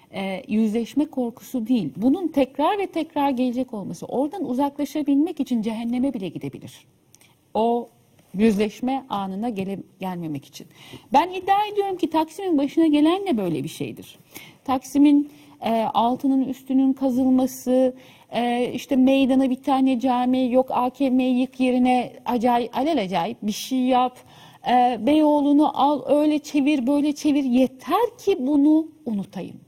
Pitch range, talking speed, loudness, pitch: 235-290 Hz, 130 wpm, -22 LUFS, 260 Hz